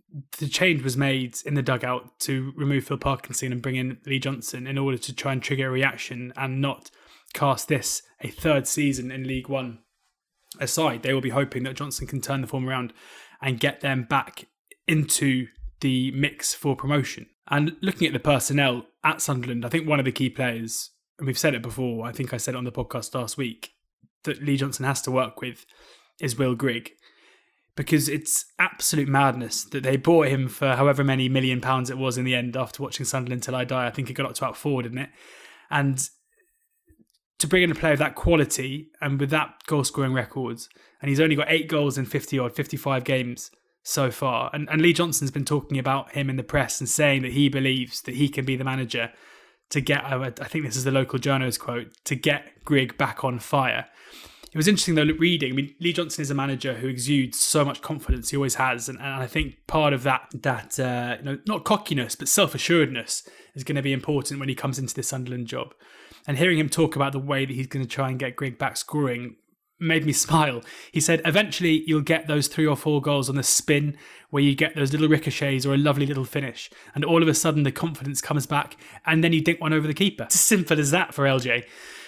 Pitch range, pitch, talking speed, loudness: 130-150 Hz, 140 Hz, 225 wpm, -24 LUFS